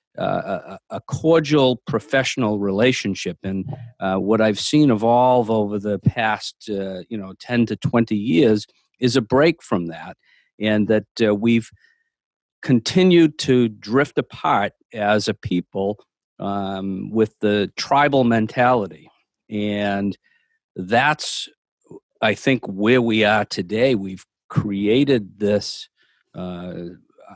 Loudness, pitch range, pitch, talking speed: -20 LUFS, 100-130 Hz, 110 Hz, 120 wpm